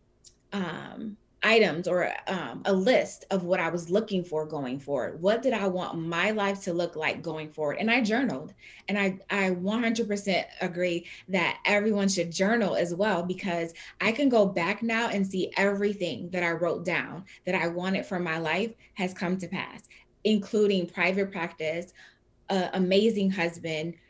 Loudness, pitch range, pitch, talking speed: -28 LUFS, 170-205 Hz, 190 Hz, 170 wpm